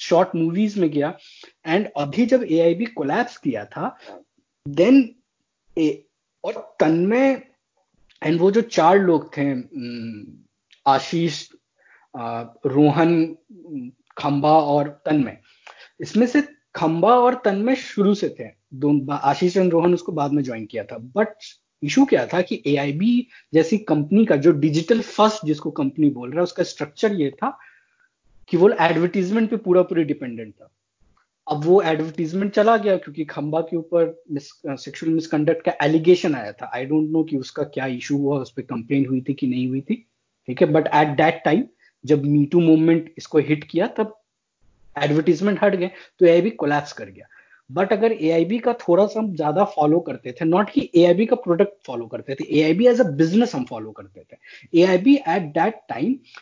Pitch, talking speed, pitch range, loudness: 165 Hz, 175 wpm, 145-210 Hz, -20 LUFS